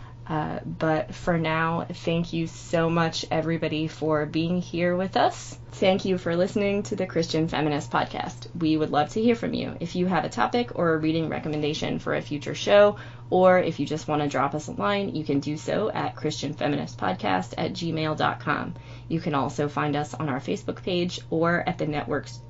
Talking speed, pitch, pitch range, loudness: 195 wpm, 155 Hz, 145-170 Hz, -26 LUFS